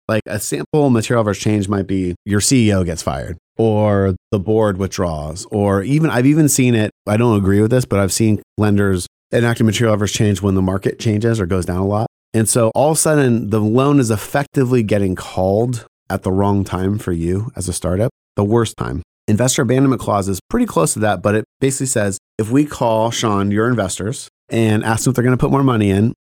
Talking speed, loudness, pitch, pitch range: 220 wpm, -17 LUFS, 110 Hz, 100-120 Hz